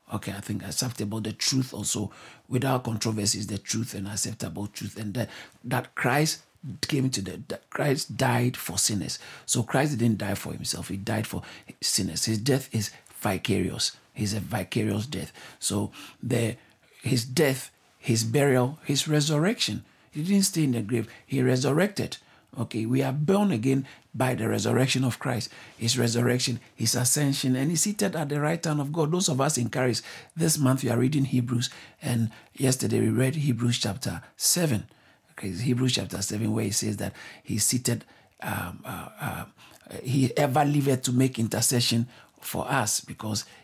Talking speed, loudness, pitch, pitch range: 170 wpm, -27 LUFS, 125 Hz, 110-135 Hz